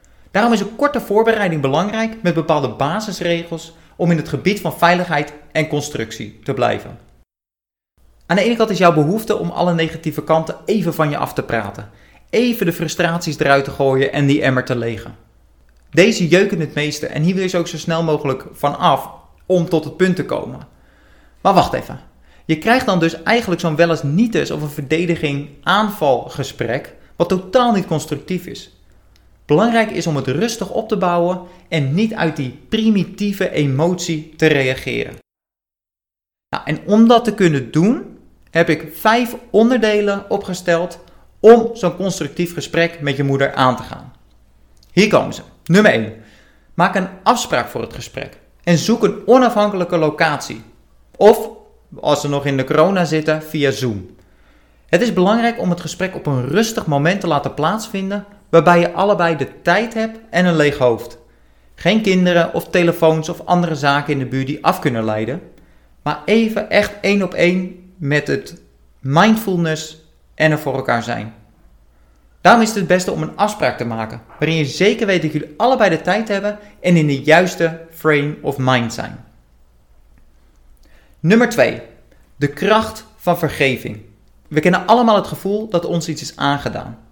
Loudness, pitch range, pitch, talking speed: -16 LUFS, 135-190 Hz, 165 Hz, 170 wpm